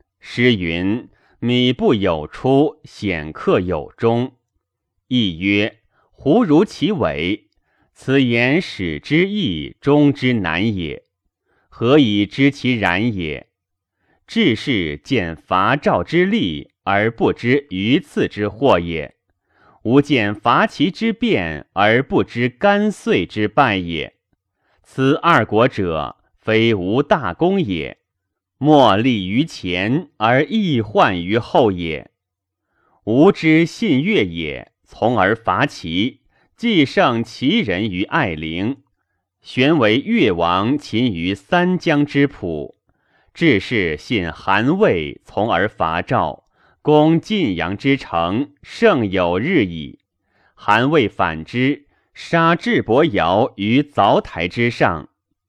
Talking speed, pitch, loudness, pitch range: 145 characters per minute, 120 Hz, -17 LUFS, 95-145 Hz